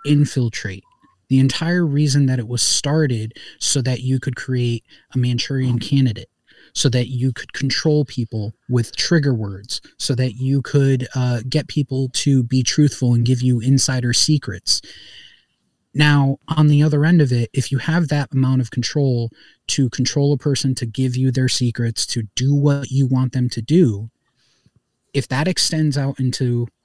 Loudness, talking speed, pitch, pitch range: -18 LUFS, 170 wpm, 130 Hz, 125-145 Hz